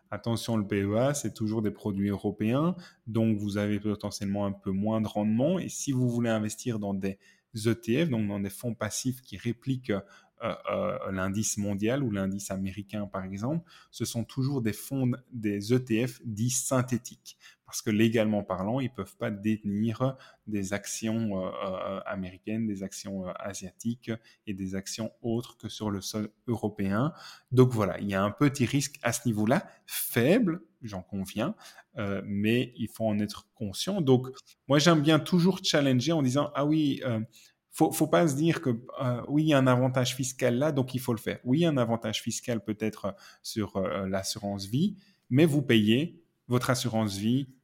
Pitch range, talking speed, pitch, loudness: 105-130 Hz, 185 wpm, 115 Hz, -29 LUFS